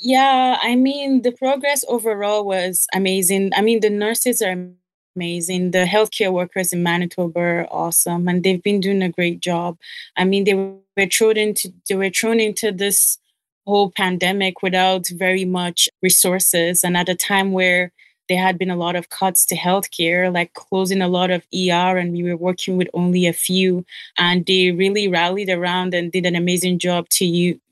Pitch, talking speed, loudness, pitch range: 185 Hz, 190 wpm, -18 LUFS, 180-195 Hz